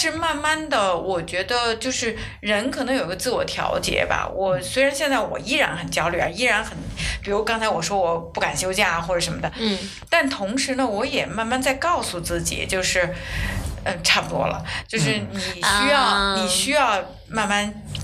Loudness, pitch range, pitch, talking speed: -22 LUFS, 185-270 Hz, 215 Hz, 275 characters per minute